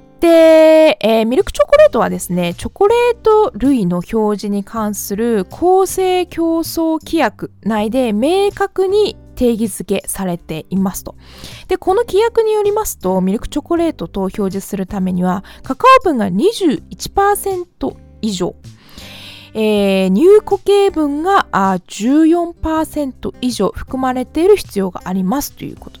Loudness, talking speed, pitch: -14 LUFS, 270 characters per minute, 265 Hz